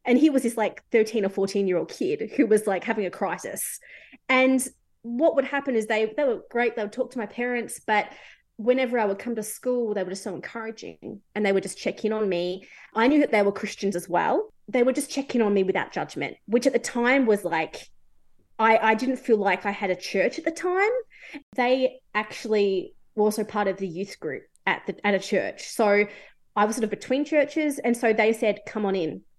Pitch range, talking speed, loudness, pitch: 205-255 Hz, 235 wpm, -25 LUFS, 220 Hz